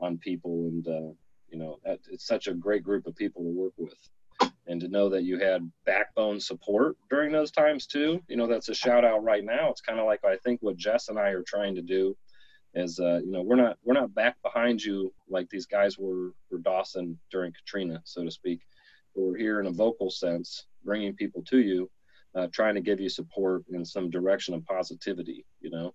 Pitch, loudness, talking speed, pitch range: 95 Hz, -29 LUFS, 220 wpm, 90-105 Hz